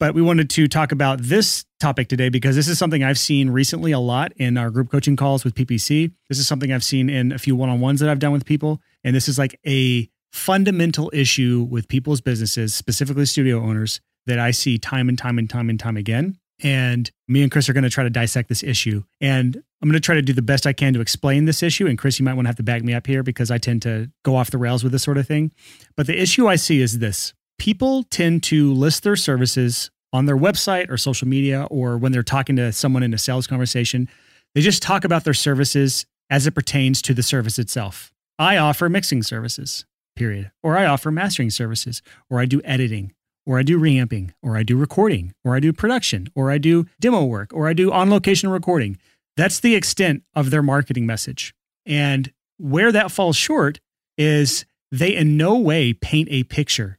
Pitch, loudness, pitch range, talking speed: 135 Hz, -19 LUFS, 125-155 Hz, 225 wpm